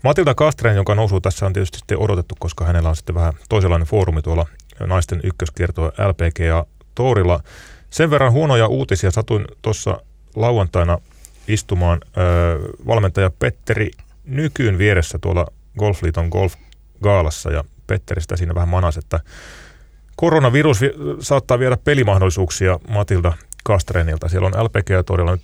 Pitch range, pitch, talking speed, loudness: 85-110 Hz, 95 Hz, 130 wpm, -18 LUFS